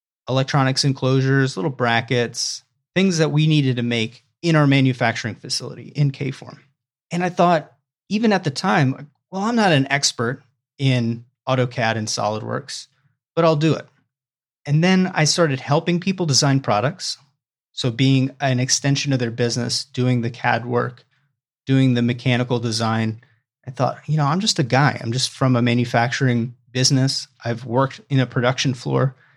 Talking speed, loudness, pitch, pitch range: 165 wpm, -20 LUFS, 130 Hz, 120-145 Hz